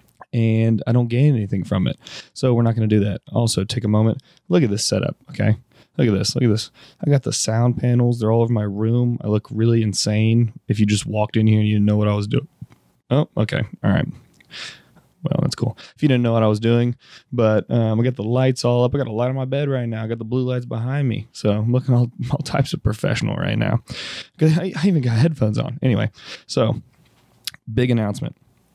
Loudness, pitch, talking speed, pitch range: -20 LUFS, 120 Hz, 240 wpm, 110-130 Hz